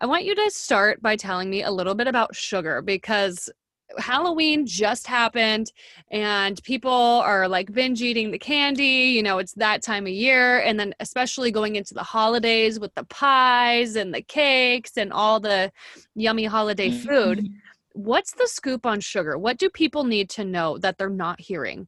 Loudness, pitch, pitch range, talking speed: -21 LUFS, 220 Hz, 200-255 Hz, 180 wpm